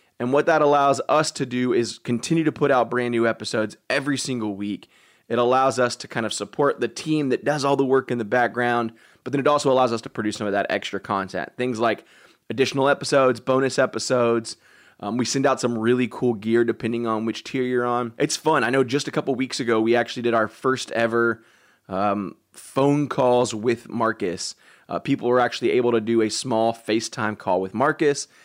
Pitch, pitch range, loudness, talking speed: 125 Hz, 115-135 Hz, -22 LUFS, 215 wpm